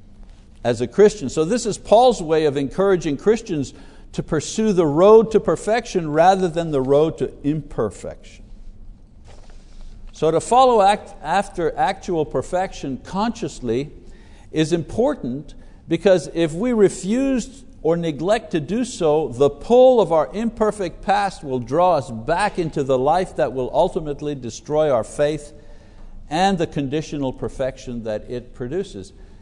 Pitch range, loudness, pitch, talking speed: 130-195 Hz, -19 LUFS, 160 Hz, 140 wpm